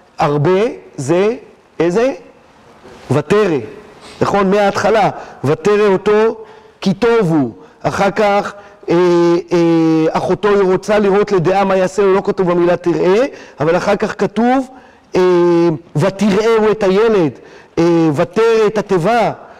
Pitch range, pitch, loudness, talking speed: 175-210 Hz, 195 Hz, -14 LUFS, 120 wpm